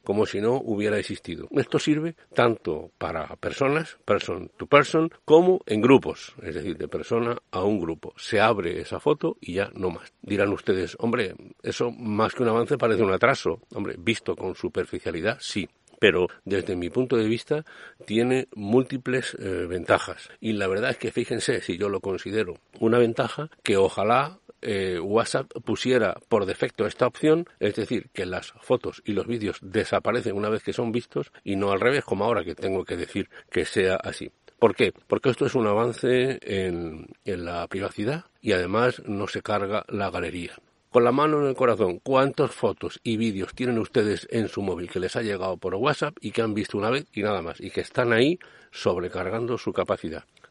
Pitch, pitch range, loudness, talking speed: 115 Hz, 100-130 Hz, -25 LUFS, 190 wpm